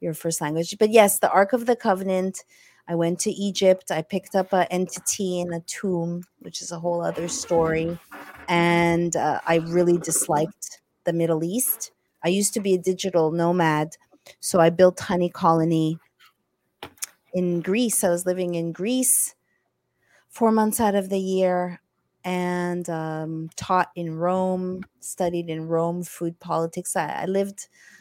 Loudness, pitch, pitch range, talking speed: -23 LUFS, 175 Hz, 170-190 Hz, 160 wpm